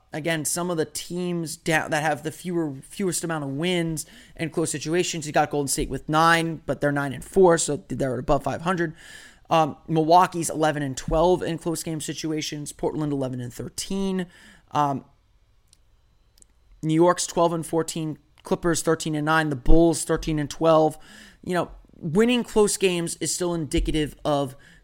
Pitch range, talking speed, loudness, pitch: 150-170 Hz, 165 wpm, -24 LUFS, 160 Hz